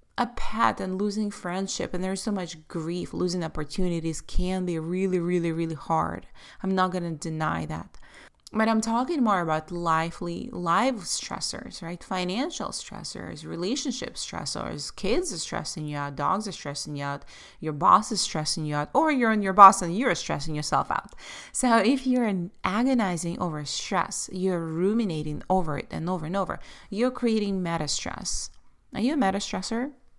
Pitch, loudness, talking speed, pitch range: 185 Hz, -26 LUFS, 170 wpm, 165-215 Hz